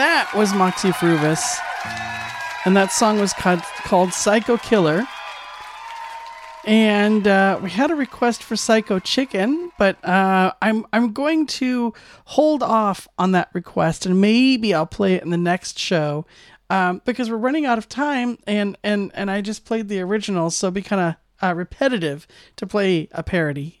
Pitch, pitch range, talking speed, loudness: 205 Hz, 185-235 Hz, 170 wpm, -20 LUFS